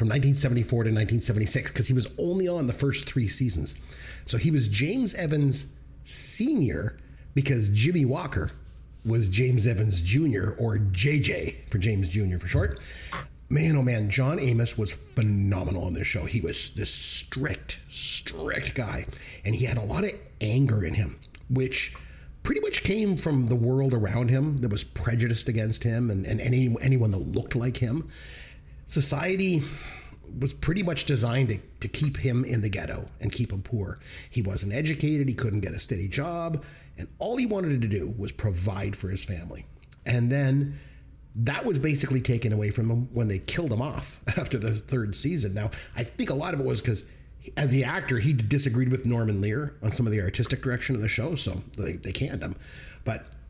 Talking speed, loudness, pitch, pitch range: 185 wpm, -26 LUFS, 120 Hz, 100-135 Hz